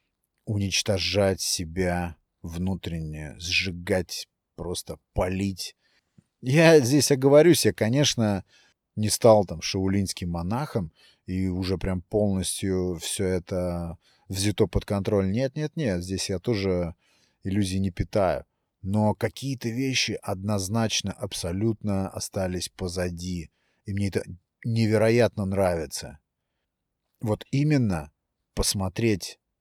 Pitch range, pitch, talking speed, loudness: 90-110 Hz, 100 Hz, 100 wpm, -25 LUFS